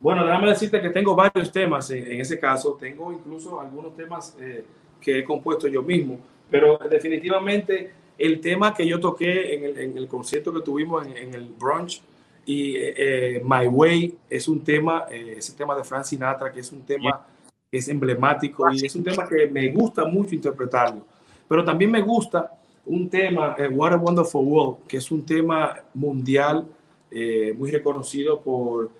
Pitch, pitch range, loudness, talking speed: 155 Hz, 135-175 Hz, -22 LUFS, 185 wpm